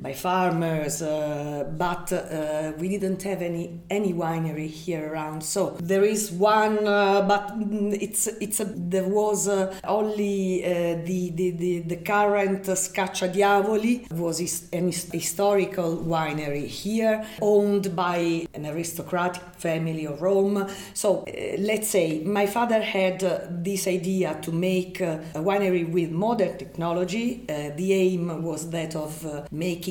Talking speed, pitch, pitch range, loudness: 150 wpm, 180 Hz, 165-200 Hz, -25 LUFS